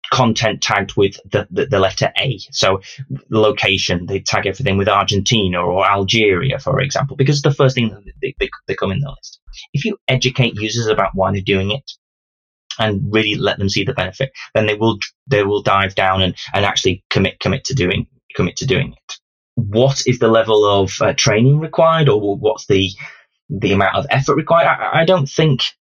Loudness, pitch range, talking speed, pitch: -16 LUFS, 100-135 Hz, 195 wpm, 110 Hz